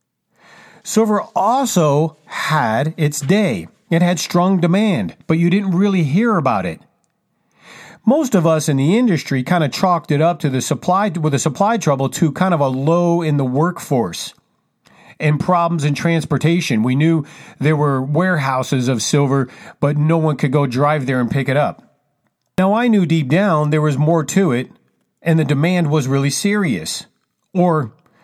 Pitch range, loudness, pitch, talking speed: 145-185 Hz, -17 LUFS, 160 Hz, 170 wpm